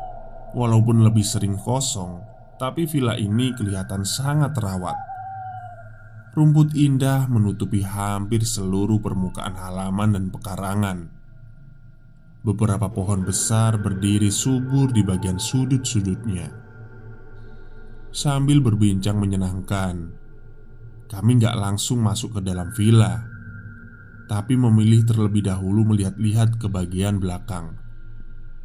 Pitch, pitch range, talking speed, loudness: 110 Hz, 100-120 Hz, 95 wpm, -21 LUFS